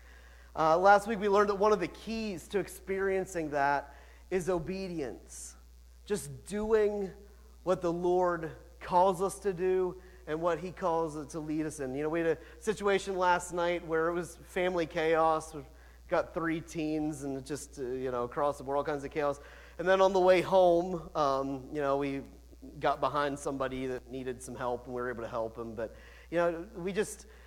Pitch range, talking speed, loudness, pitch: 140-185 Hz, 200 wpm, -31 LUFS, 160 Hz